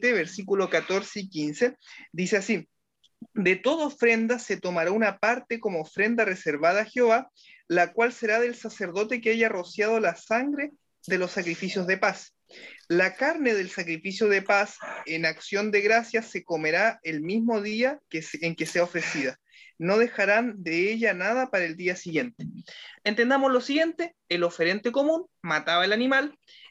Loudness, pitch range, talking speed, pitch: -26 LUFS, 180-235 Hz, 160 wpm, 210 Hz